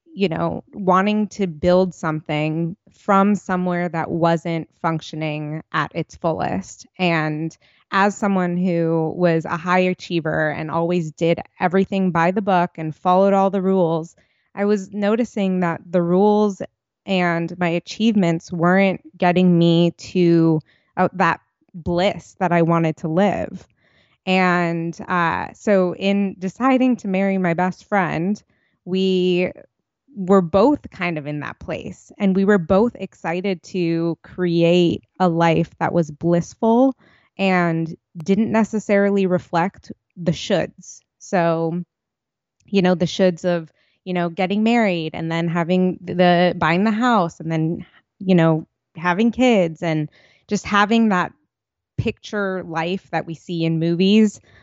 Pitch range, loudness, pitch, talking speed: 165-195 Hz, -20 LUFS, 180 Hz, 135 wpm